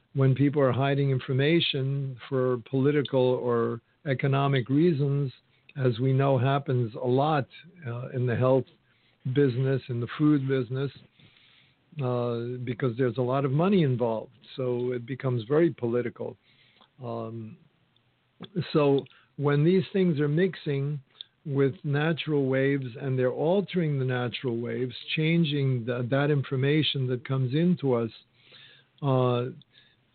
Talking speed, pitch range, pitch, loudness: 125 wpm, 125-145 Hz, 135 Hz, -27 LUFS